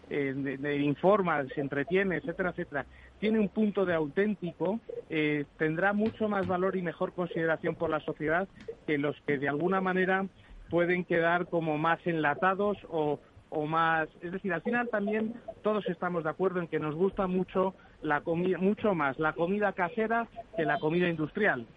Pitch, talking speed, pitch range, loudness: 175 Hz, 175 wpm, 155-195 Hz, -30 LUFS